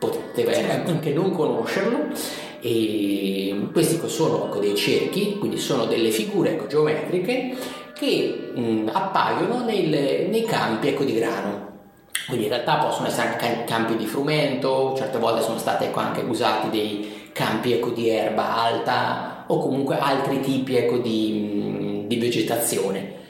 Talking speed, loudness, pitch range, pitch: 120 wpm, -23 LUFS, 105-135 Hz, 115 Hz